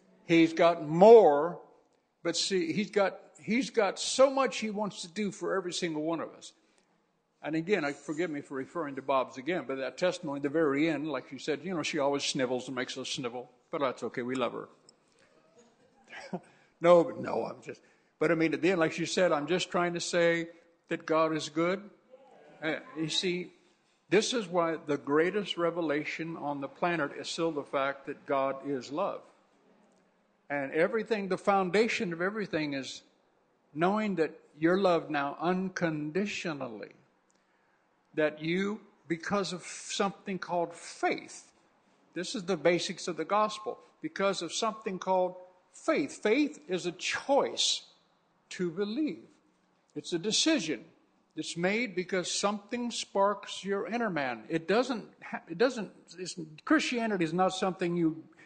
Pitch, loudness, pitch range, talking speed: 175 Hz, -30 LUFS, 160-205 Hz, 160 wpm